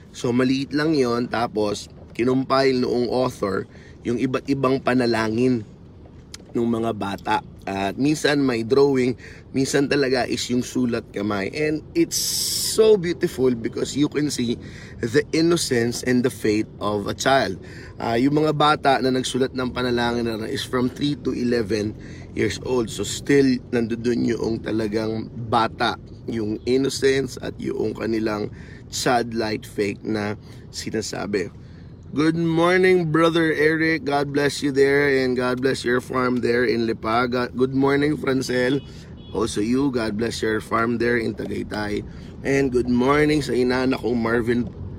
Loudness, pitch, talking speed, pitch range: -22 LUFS, 125 Hz, 150 wpm, 115-140 Hz